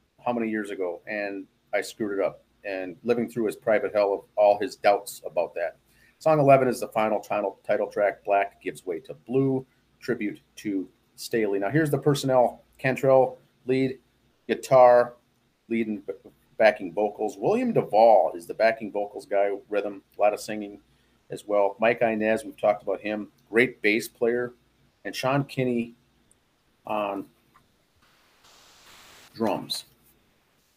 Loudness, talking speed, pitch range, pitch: -25 LUFS, 145 wpm, 105-125 Hz, 115 Hz